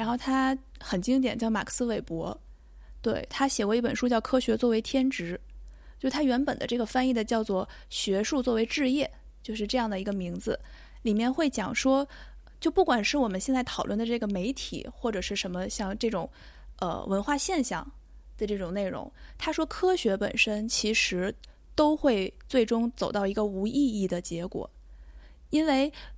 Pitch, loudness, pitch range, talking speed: 230 Hz, -28 LUFS, 195-265 Hz, 265 characters per minute